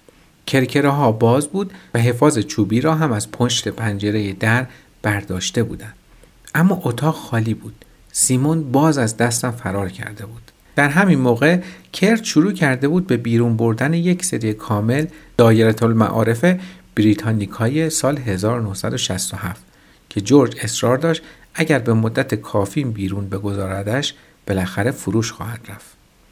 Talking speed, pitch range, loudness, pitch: 135 wpm, 105-150 Hz, -18 LUFS, 120 Hz